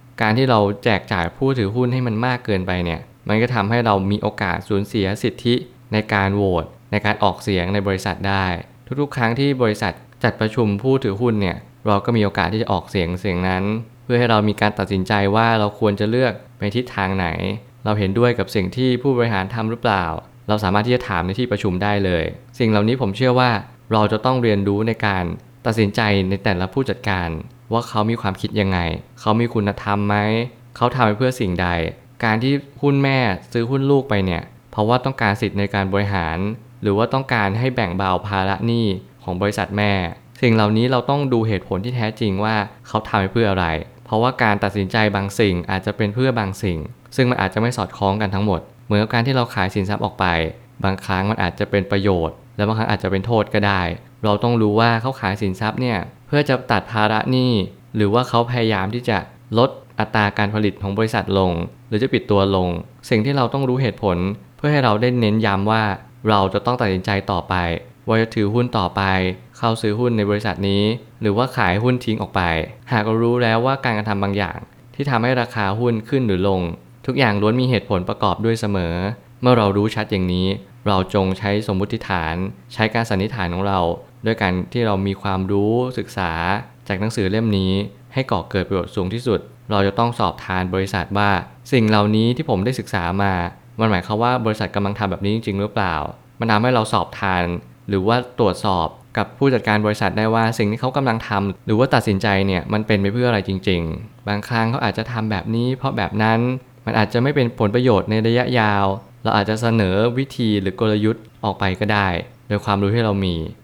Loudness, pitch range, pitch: -20 LUFS, 100-120 Hz, 105 Hz